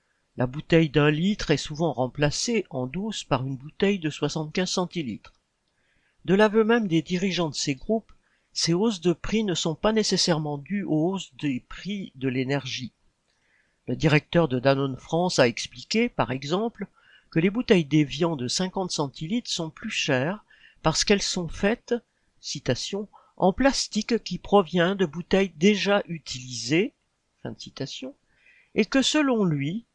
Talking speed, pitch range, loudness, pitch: 155 wpm, 150-205 Hz, -25 LUFS, 175 Hz